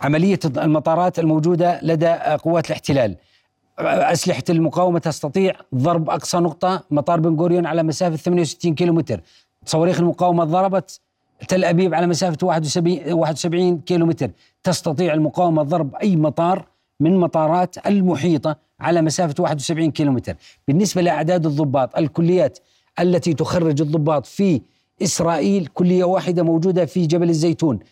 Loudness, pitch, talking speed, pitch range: -19 LUFS, 170 Hz, 120 wpm, 155-180 Hz